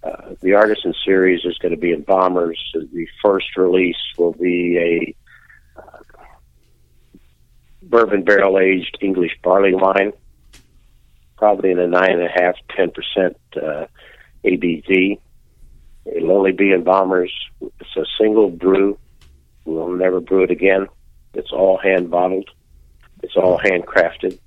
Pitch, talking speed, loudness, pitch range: 90 Hz, 135 wpm, -17 LUFS, 70-95 Hz